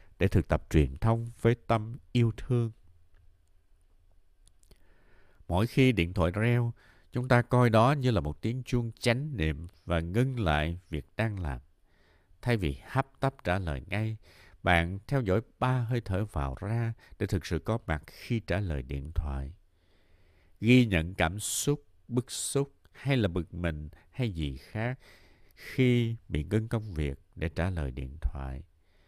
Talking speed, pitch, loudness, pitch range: 165 wpm, 95 Hz, -30 LUFS, 80-115 Hz